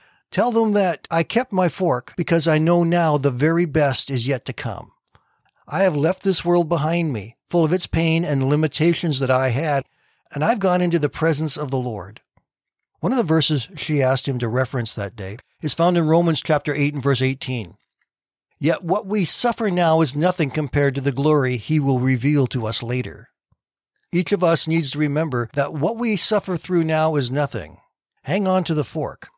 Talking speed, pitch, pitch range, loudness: 200 wpm, 155 Hz, 135-170 Hz, -19 LUFS